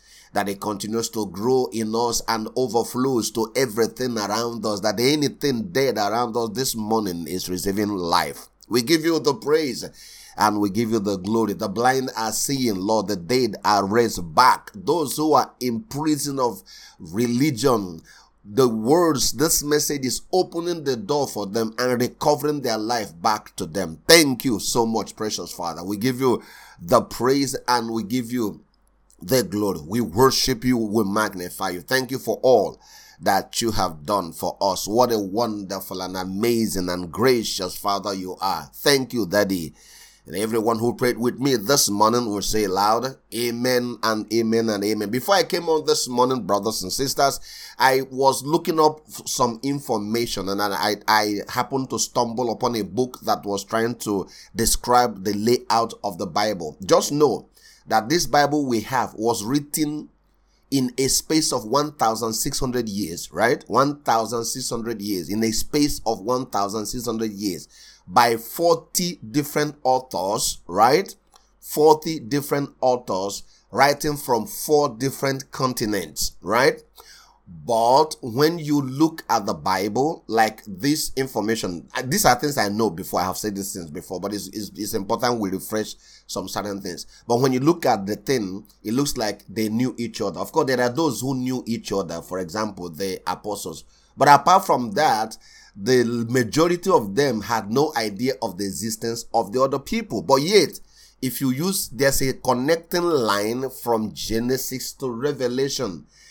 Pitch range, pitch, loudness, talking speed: 105-135 Hz, 120 Hz, -22 LUFS, 165 wpm